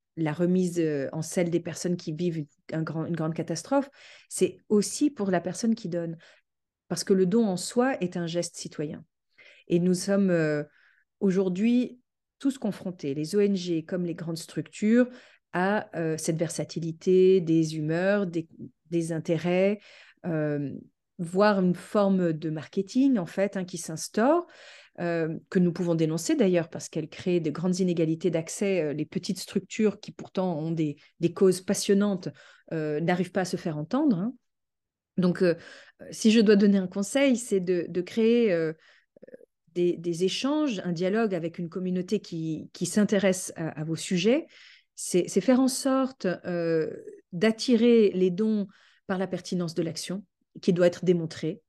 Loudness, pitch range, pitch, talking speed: -27 LUFS, 165-210 Hz, 185 Hz, 160 wpm